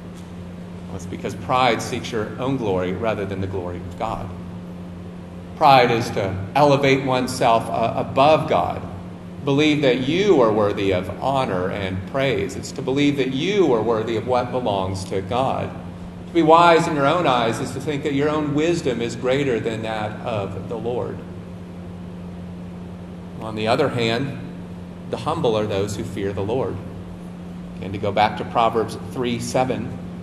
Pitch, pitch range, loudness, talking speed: 95 Hz, 90-125 Hz, -21 LUFS, 165 wpm